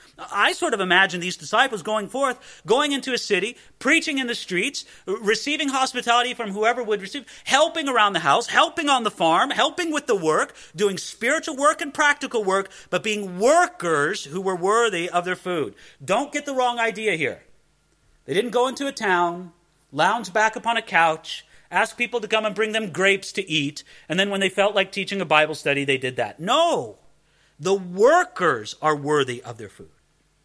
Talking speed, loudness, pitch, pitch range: 190 wpm, -22 LUFS, 210 Hz, 175-250 Hz